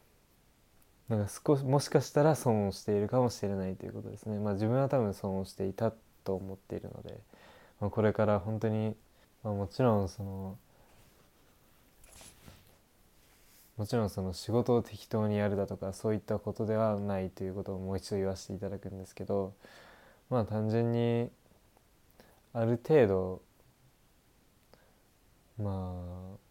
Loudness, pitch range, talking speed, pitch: -33 LUFS, 95-115 Hz, 305 characters per minute, 105 Hz